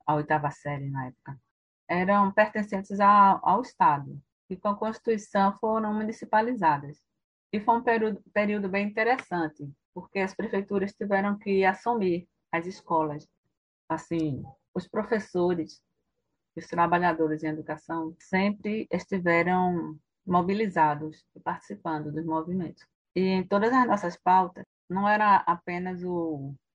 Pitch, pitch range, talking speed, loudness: 180 Hz, 160-205 Hz, 120 wpm, -27 LUFS